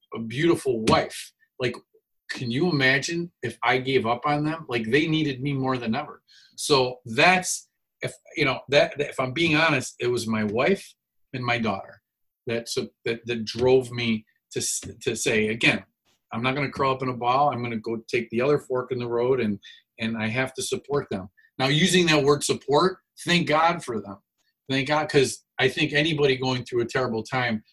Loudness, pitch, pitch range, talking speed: -24 LUFS, 130 Hz, 120-155 Hz, 205 wpm